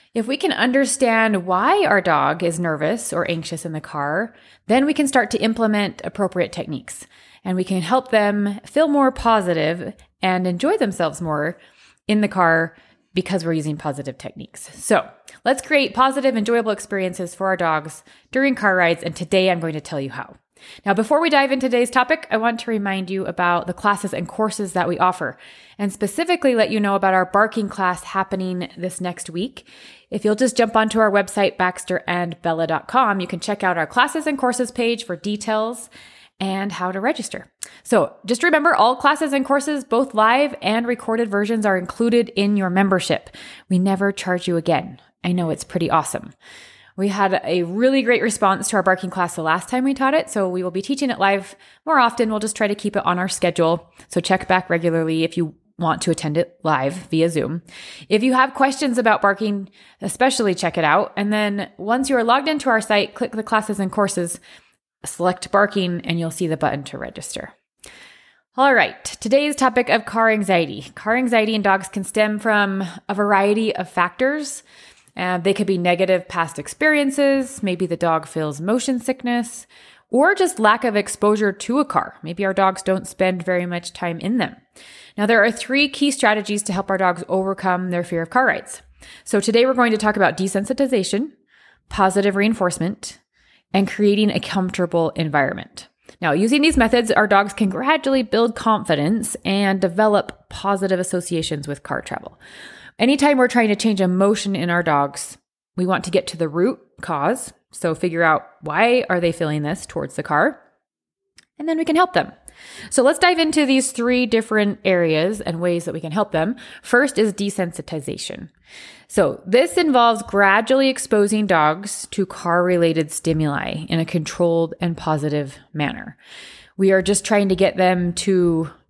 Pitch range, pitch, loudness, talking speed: 175-235 Hz, 200 Hz, -19 LUFS, 185 wpm